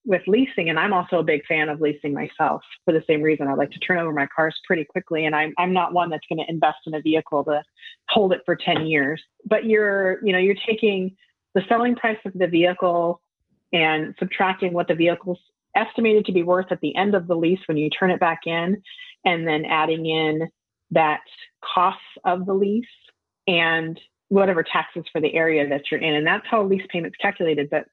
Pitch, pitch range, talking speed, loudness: 175 Hz, 160-195 Hz, 215 wpm, -21 LUFS